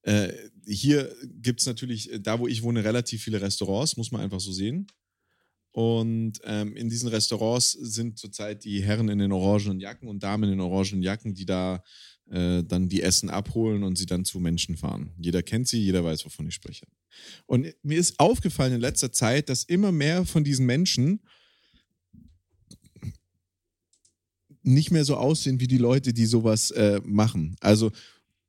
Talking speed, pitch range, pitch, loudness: 170 wpm, 95-125 Hz, 110 Hz, -25 LUFS